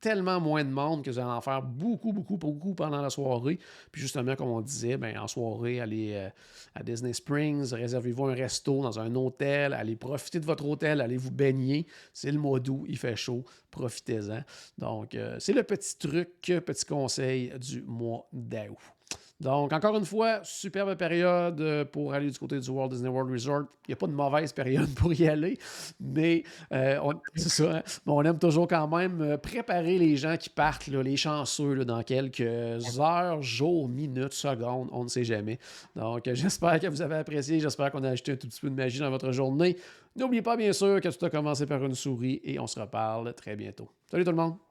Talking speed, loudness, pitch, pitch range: 205 wpm, -30 LUFS, 140 Hz, 125-165 Hz